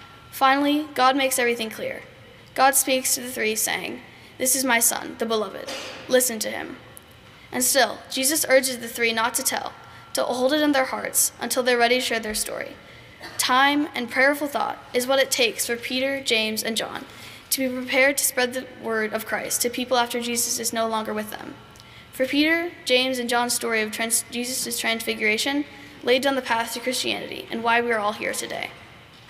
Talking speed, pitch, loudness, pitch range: 195 wpm, 250 Hz, -22 LUFS, 230-270 Hz